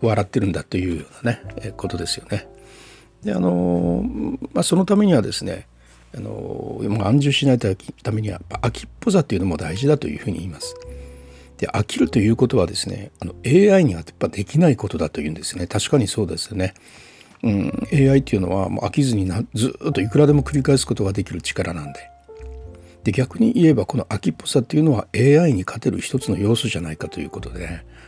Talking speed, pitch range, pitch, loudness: 425 characters per minute, 90-130 Hz, 105 Hz, -20 LUFS